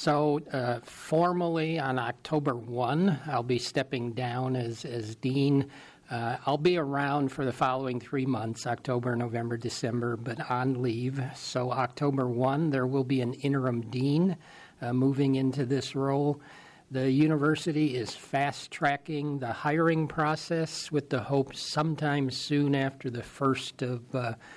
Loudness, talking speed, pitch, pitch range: -29 LUFS, 145 wpm, 135 Hz, 125-150 Hz